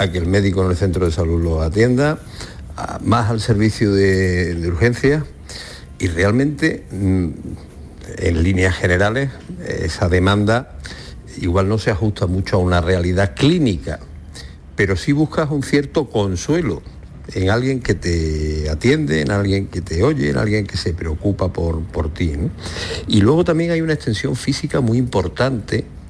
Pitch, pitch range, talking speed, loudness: 100 Hz, 90-120 Hz, 155 wpm, -18 LUFS